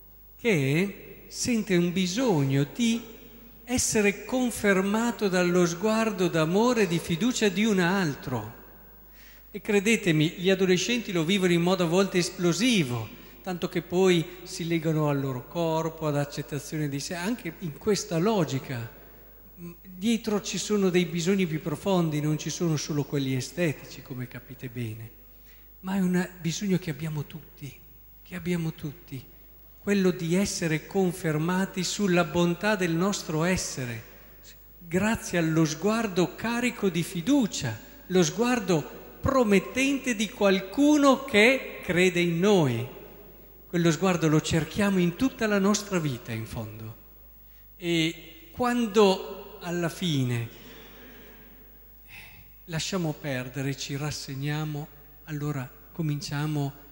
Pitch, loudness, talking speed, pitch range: 175 Hz, -26 LUFS, 120 wpm, 150-200 Hz